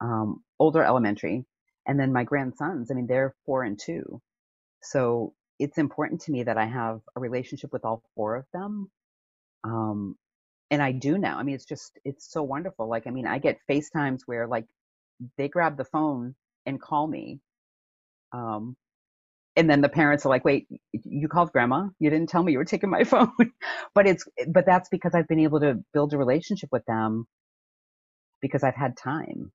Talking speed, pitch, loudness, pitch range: 190 wpm, 140 Hz, -26 LUFS, 120-160 Hz